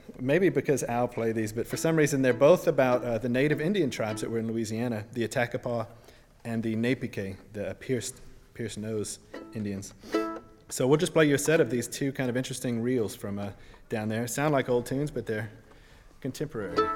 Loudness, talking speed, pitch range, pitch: -28 LUFS, 200 wpm, 110-130 Hz, 120 Hz